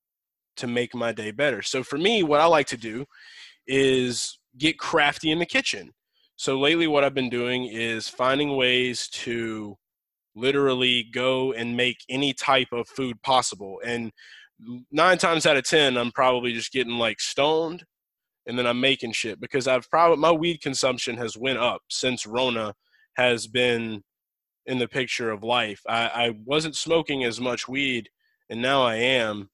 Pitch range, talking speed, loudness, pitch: 115-140 Hz, 170 wpm, -23 LUFS, 125 Hz